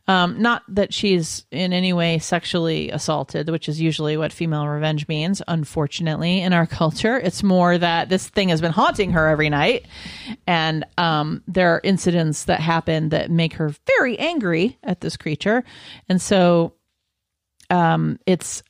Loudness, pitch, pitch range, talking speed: -20 LUFS, 170 Hz, 155-185 Hz, 160 wpm